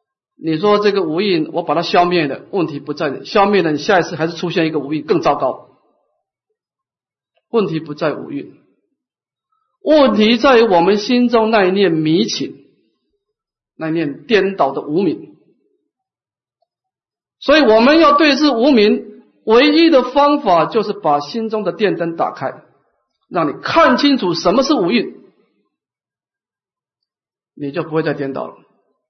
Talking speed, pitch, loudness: 215 characters per minute, 210 Hz, -14 LUFS